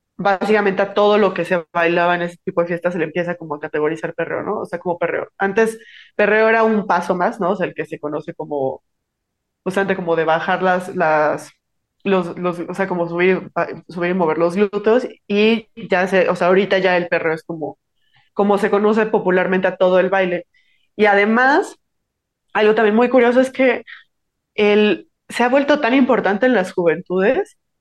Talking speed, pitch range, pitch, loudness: 195 wpm, 175-210 Hz, 185 Hz, -17 LUFS